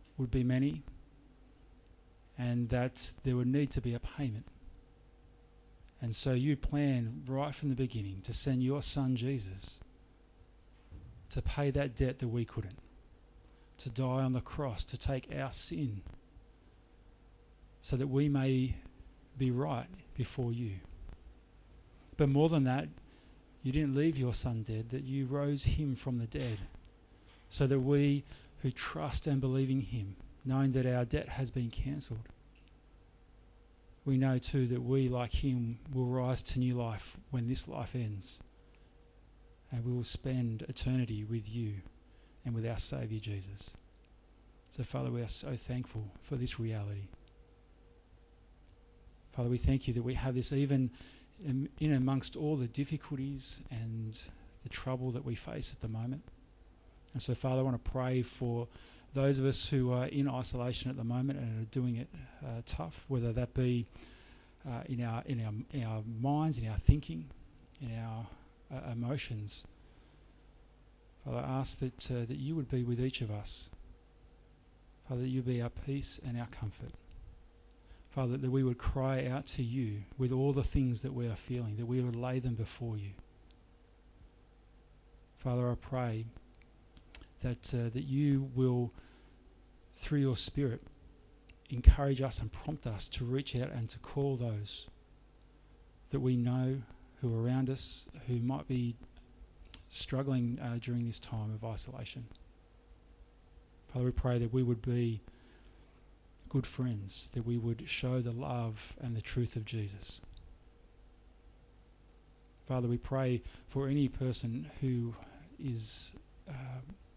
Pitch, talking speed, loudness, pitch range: 120 Hz, 155 wpm, -36 LUFS, 110-130 Hz